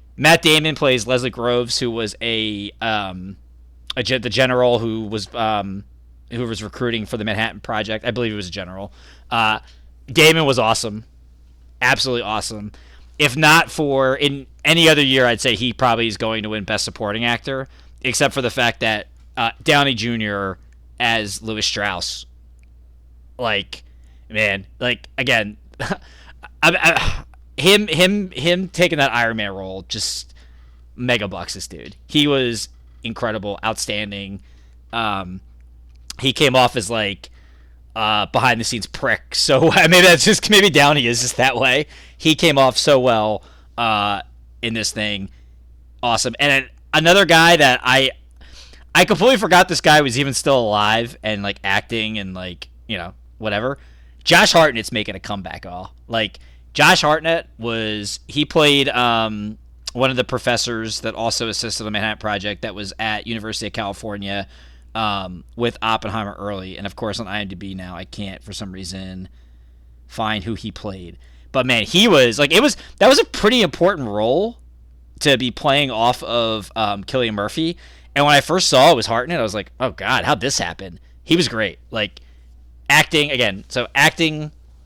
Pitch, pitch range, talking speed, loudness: 110 Hz, 90-125 Hz, 165 wpm, -17 LUFS